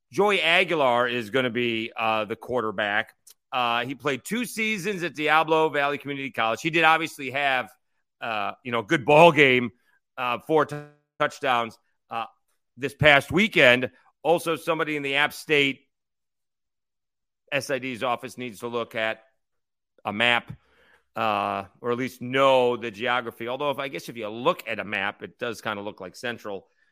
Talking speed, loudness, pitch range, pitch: 165 wpm, -24 LUFS, 120-150 Hz, 135 Hz